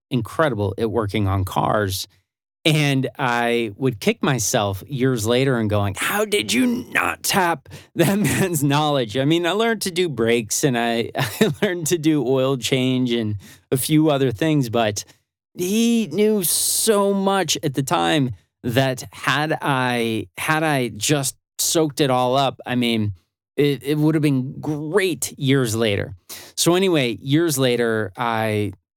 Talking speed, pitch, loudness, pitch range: 155 wpm, 130 Hz, -20 LUFS, 115-155 Hz